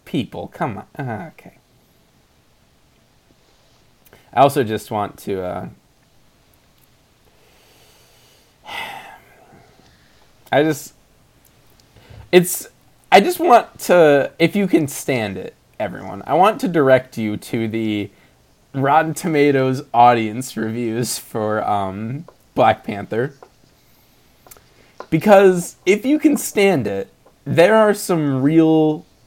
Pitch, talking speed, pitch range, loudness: 135 Hz, 100 wpm, 110-160 Hz, -17 LUFS